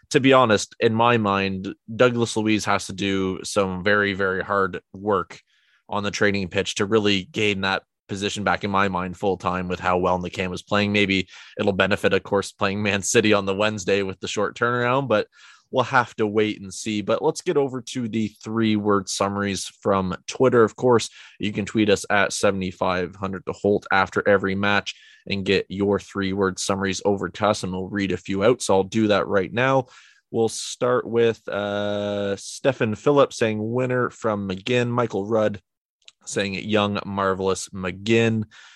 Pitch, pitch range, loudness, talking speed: 100 Hz, 95-110 Hz, -22 LUFS, 185 wpm